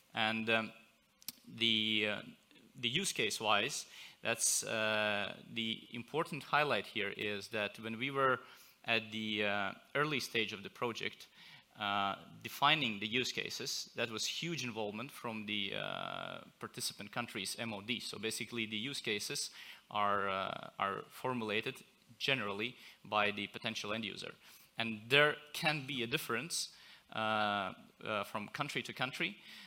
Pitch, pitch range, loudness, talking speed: 115 Hz, 105-125 Hz, -36 LUFS, 140 wpm